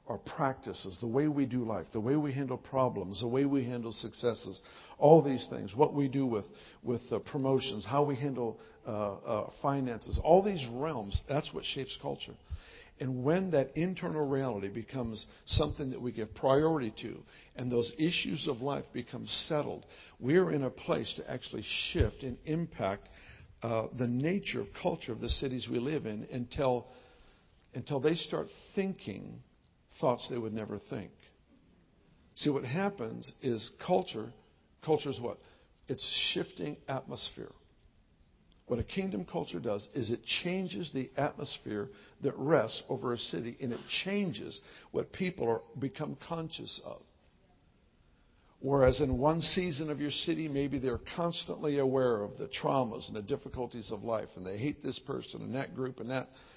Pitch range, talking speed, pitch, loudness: 115-150 Hz, 160 wpm, 130 Hz, -34 LUFS